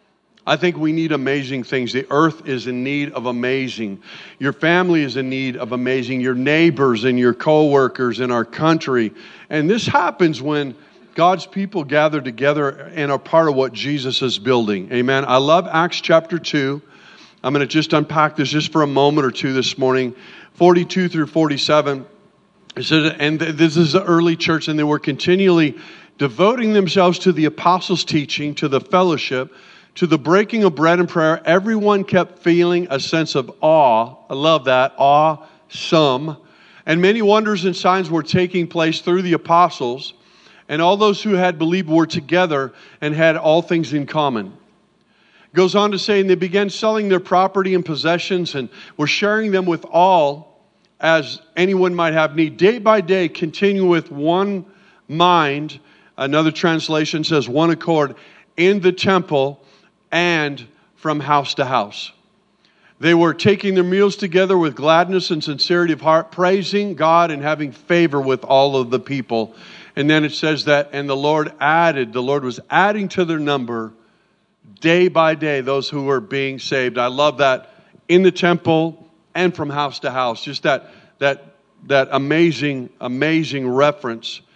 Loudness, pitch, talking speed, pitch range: -17 LUFS, 155 Hz, 170 wpm, 140-180 Hz